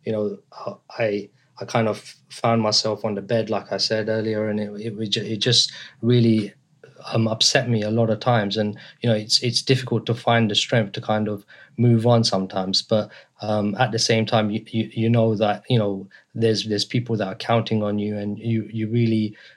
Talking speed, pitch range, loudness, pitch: 210 wpm, 105-115 Hz, -21 LUFS, 110 Hz